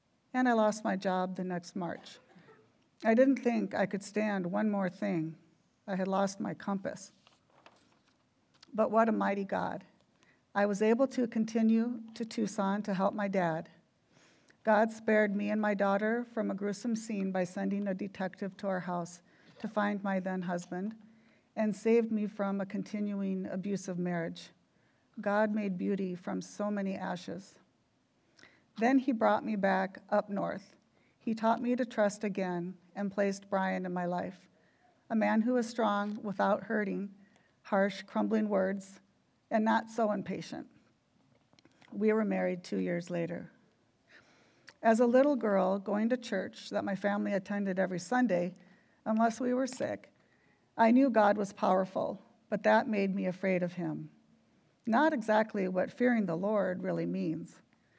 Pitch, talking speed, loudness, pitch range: 205 Hz, 155 wpm, -32 LUFS, 190-220 Hz